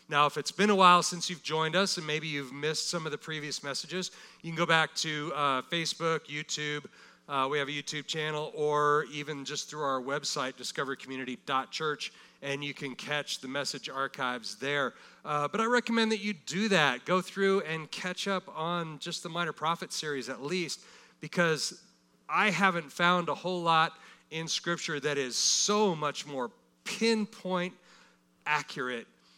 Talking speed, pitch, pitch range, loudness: 175 wpm, 155 Hz, 145-180 Hz, -30 LUFS